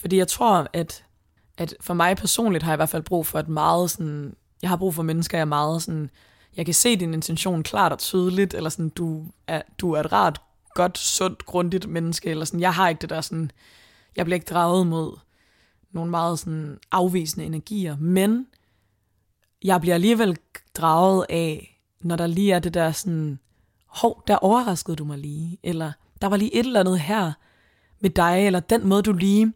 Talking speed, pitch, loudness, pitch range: 200 wpm, 170 Hz, -23 LUFS, 160-185 Hz